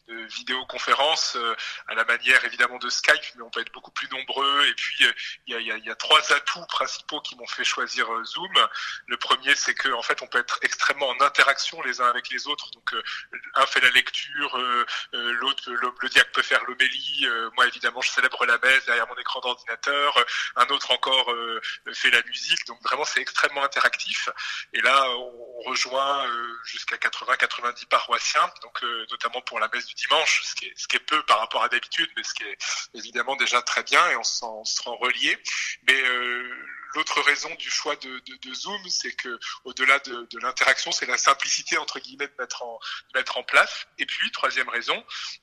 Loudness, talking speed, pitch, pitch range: -23 LUFS, 215 wpm, 130 Hz, 120-145 Hz